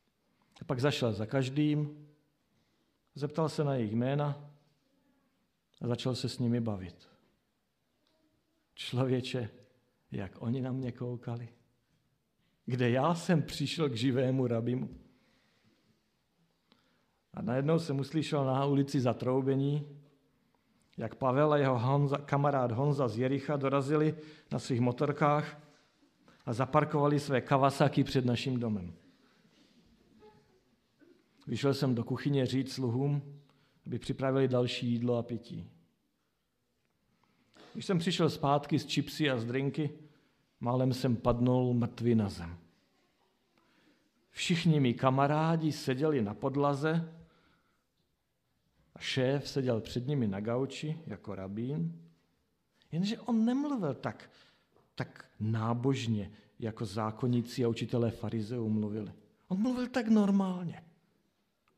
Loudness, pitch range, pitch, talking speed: -32 LUFS, 120-150 Hz, 135 Hz, 110 wpm